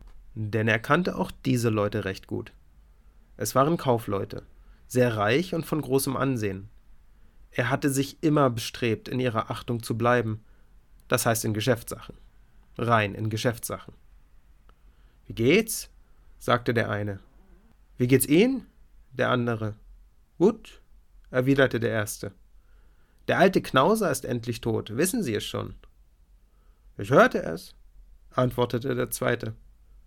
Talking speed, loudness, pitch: 130 wpm, -26 LUFS, 110 Hz